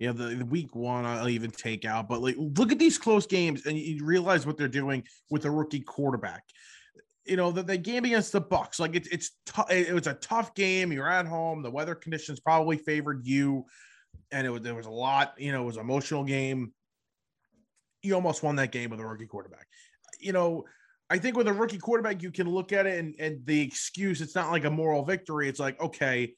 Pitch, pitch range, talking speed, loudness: 155 Hz, 135-185 Hz, 230 wpm, -29 LUFS